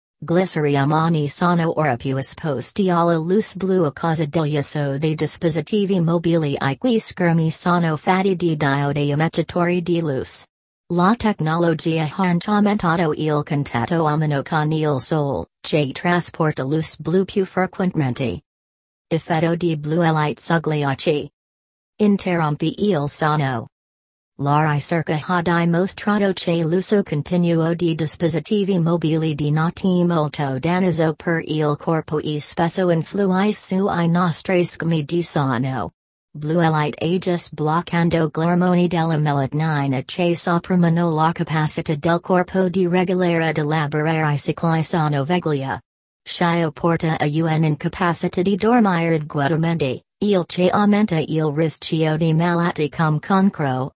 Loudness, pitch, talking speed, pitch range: -19 LUFS, 165 Hz, 125 wpm, 150-175 Hz